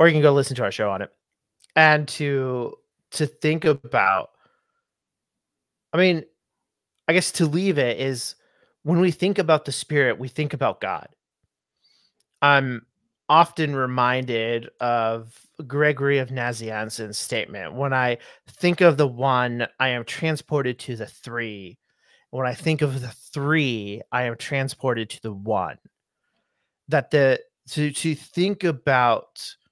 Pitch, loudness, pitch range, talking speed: 140 Hz, -22 LUFS, 125-155 Hz, 145 wpm